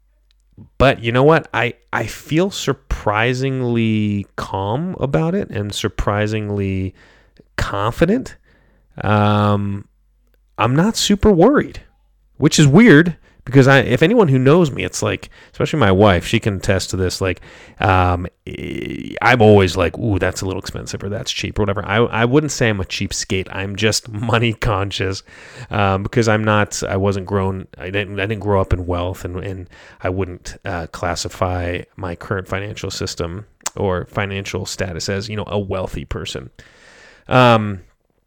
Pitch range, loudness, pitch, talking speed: 95-115 Hz, -17 LUFS, 105 Hz, 155 wpm